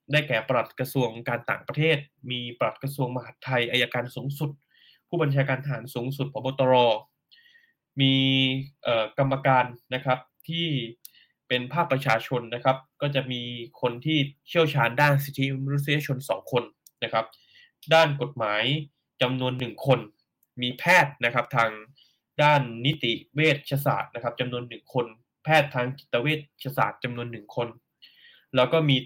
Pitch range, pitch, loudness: 120-145 Hz, 130 Hz, -25 LUFS